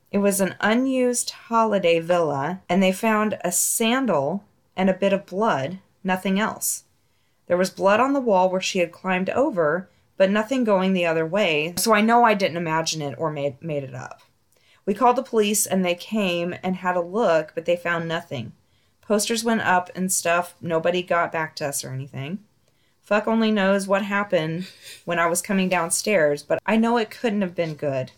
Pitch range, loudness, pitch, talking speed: 170-210 Hz, -22 LUFS, 185 Hz, 195 wpm